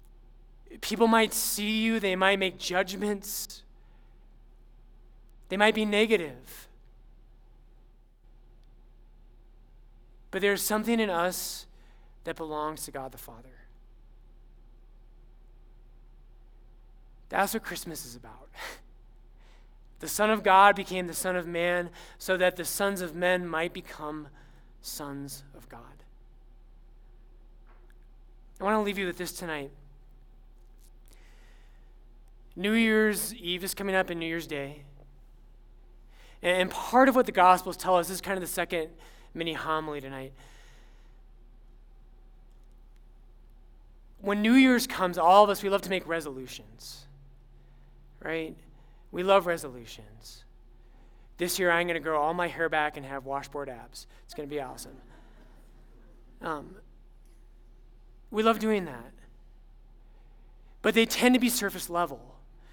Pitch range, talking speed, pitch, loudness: 125-185 Hz, 125 wpm, 145 Hz, -27 LUFS